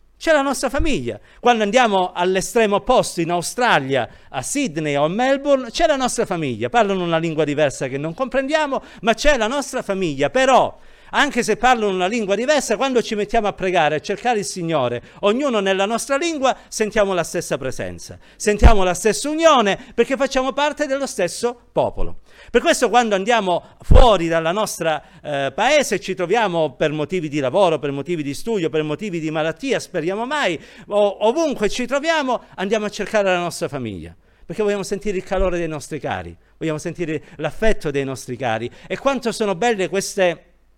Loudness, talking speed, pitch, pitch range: -19 LUFS, 175 wpm, 200 Hz, 160-245 Hz